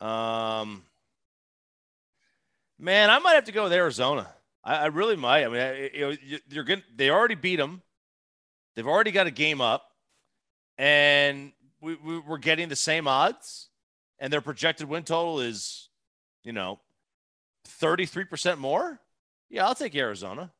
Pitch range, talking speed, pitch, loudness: 130-175 Hz, 150 wpm, 150 Hz, -25 LUFS